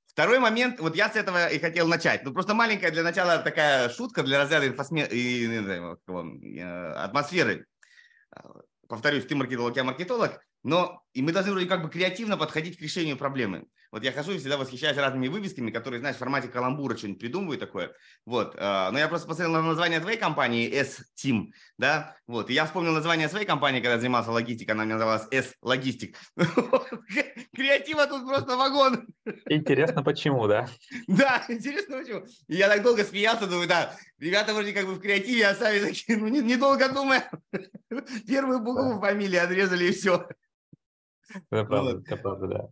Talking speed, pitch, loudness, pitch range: 175 wpm, 170 Hz, -26 LUFS, 130-215 Hz